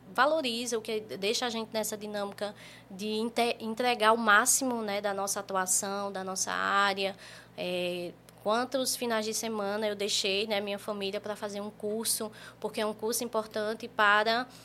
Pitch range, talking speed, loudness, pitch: 200-225 Hz, 160 wpm, -30 LUFS, 215 Hz